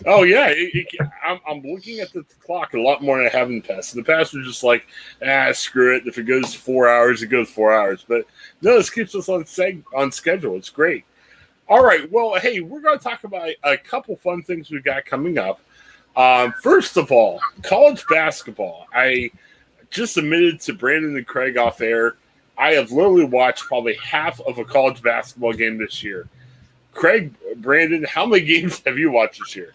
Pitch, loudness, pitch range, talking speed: 145 Hz, -18 LUFS, 125-185 Hz, 210 wpm